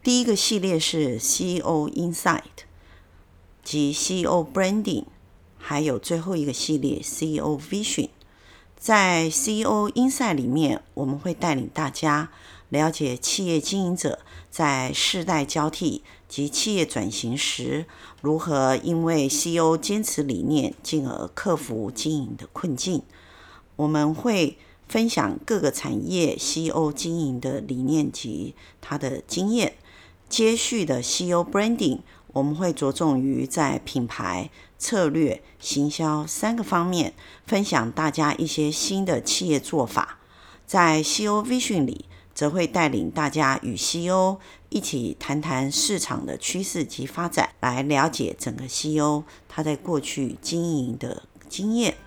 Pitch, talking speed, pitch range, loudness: 155 Hz, 240 characters per minute, 140-180 Hz, -24 LUFS